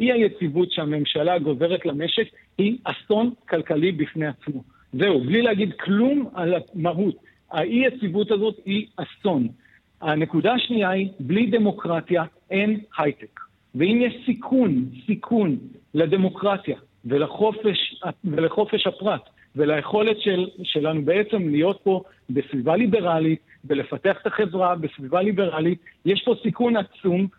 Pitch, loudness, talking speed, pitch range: 185 Hz, -23 LUFS, 115 wpm, 160-215 Hz